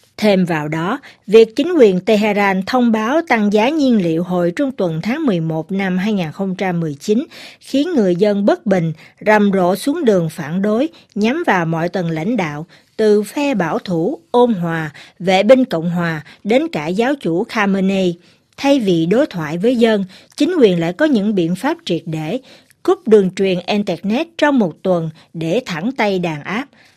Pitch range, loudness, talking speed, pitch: 175-245 Hz, -16 LUFS, 175 wpm, 200 Hz